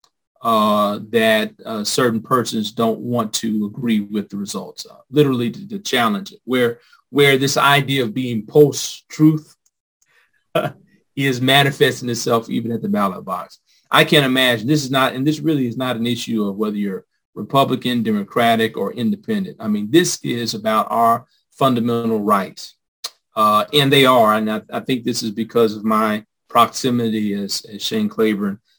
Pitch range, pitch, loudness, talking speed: 110-145 Hz, 120 Hz, -18 LUFS, 165 wpm